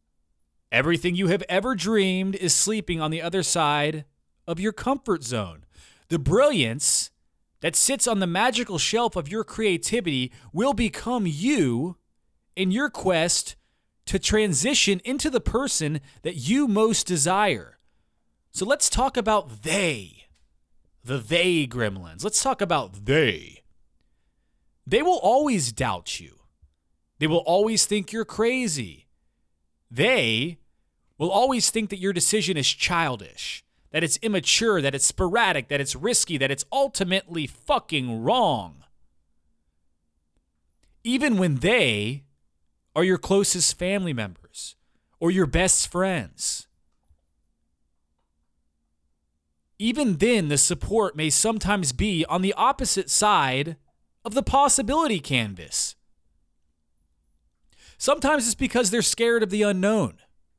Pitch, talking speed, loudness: 165 Hz, 120 wpm, -23 LUFS